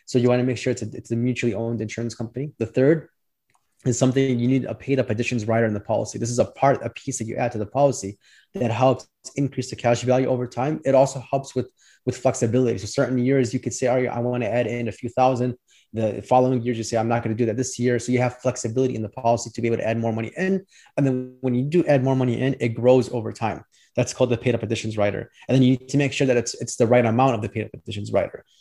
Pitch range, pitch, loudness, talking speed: 115-130 Hz, 125 Hz, -23 LUFS, 280 wpm